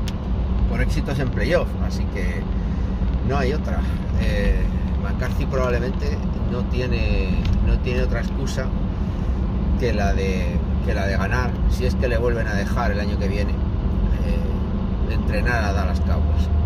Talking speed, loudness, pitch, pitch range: 155 wpm, -23 LUFS, 90 Hz, 70-95 Hz